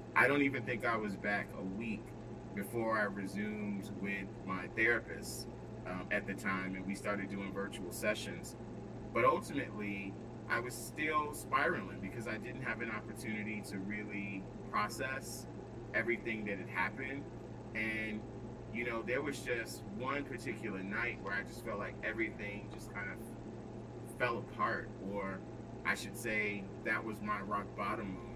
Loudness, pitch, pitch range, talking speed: -39 LUFS, 105 Hz, 100-115 Hz, 155 wpm